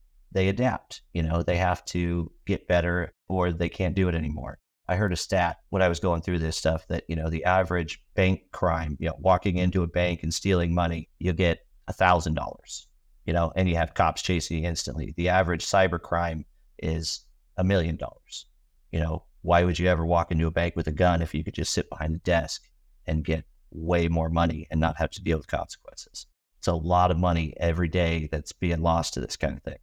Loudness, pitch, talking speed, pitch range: -26 LUFS, 85 Hz, 225 wpm, 80-90 Hz